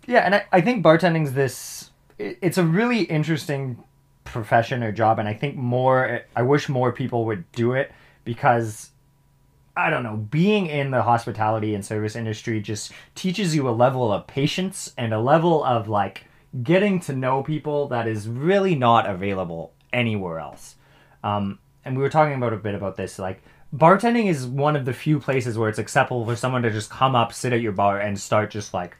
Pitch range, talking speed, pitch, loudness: 110-150 Hz, 195 wpm, 125 Hz, -22 LUFS